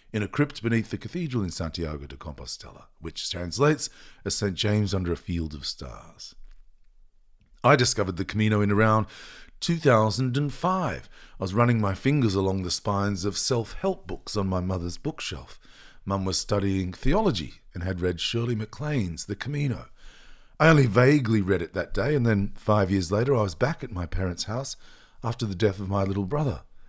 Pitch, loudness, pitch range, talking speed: 105 Hz, -26 LUFS, 95-125 Hz, 180 wpm